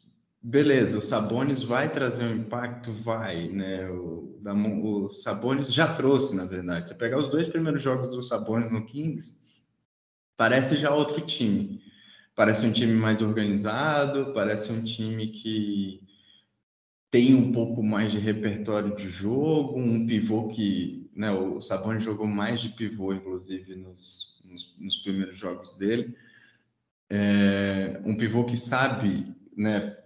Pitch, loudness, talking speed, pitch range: 110 Hz, -26 LUFS, 145 wpm, 100-120 Hz